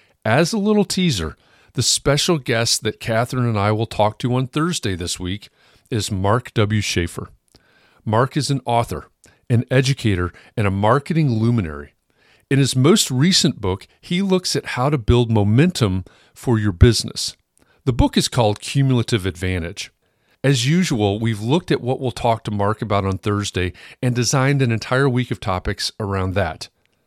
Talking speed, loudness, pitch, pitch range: 165 wpm, -19 LUFS, 120 Hz, 100-135 Hz